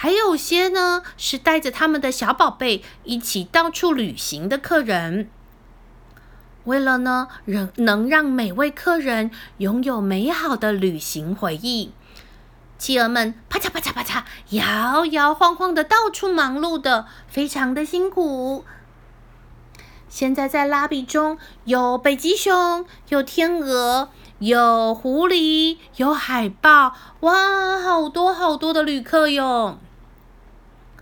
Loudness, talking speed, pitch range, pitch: -19 LUFS, 180 characters per minute, 235-330 Hz, 275 Hz